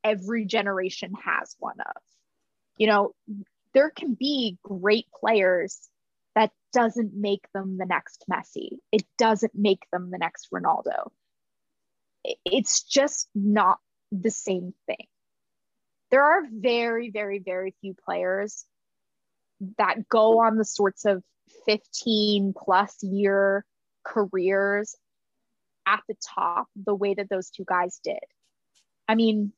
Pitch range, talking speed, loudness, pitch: 195-225 Hz, 125 wpm, -25 LUFS, 205 Hz